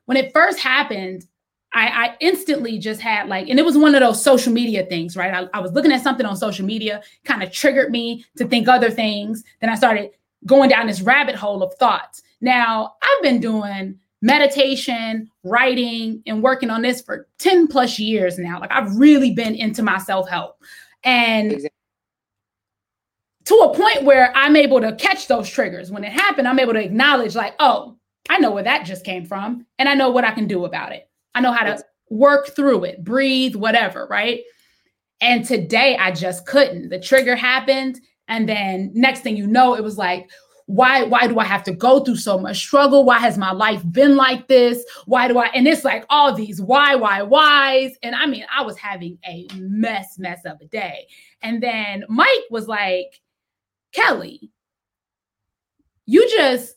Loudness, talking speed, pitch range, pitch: -16 LUFS, 190 wpm, 195-265 Hz, 235 Hz